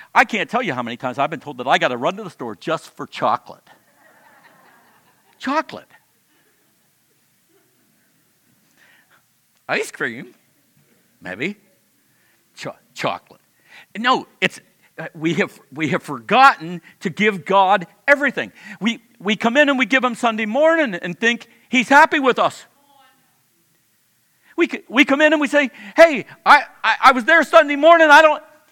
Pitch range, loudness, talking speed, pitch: 195-290 Hz, -17 LUFS, 150 wpm, 240 Hz